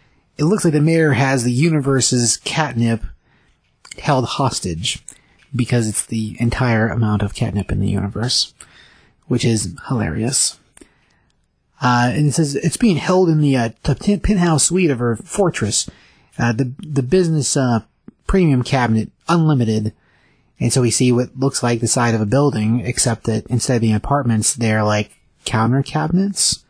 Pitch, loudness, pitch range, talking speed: 125 Hz, -17 LUFS, 115-150 Hz, 155 wpm